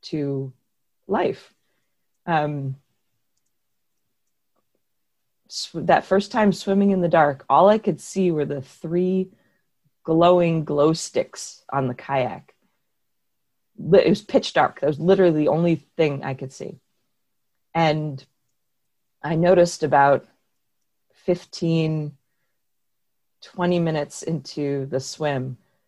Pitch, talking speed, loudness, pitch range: 155 Hz, 105 wpm, -21 LUFS, 140-175 Hz